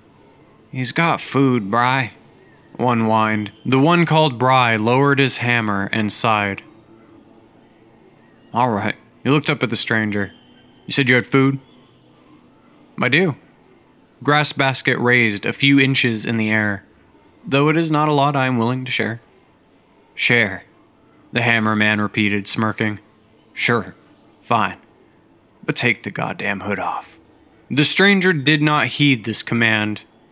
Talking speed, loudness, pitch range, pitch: 140 wpm, -17 LUFS, 110-140 Hz, 120 Hz